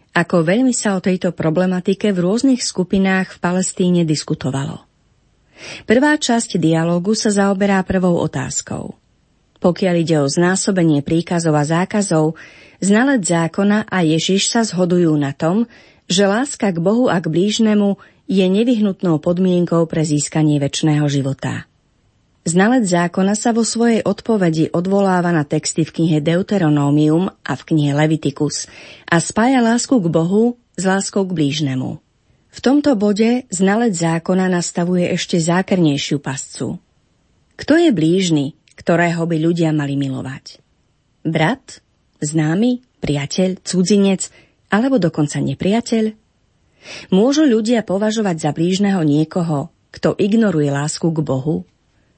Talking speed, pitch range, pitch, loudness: 125 wpm, 160-205 Hz, 180 Hz, -17 LUFS